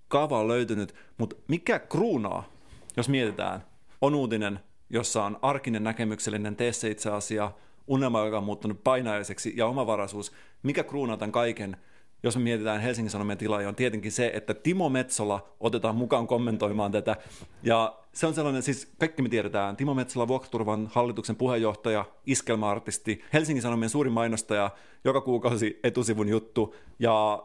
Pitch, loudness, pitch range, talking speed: 110 Hz, -28 LUFS, 105-125 Hz, 150 wpm